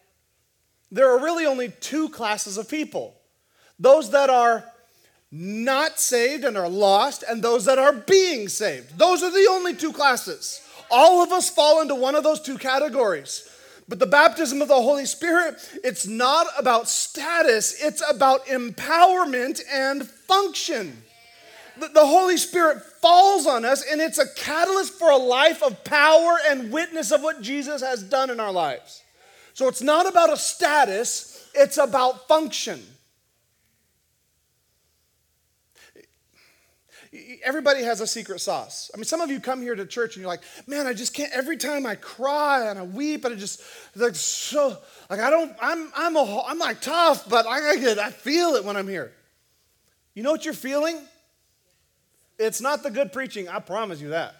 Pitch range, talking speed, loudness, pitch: 240-320 Hz, 170 wpm, -21 LUFS, 280 Hz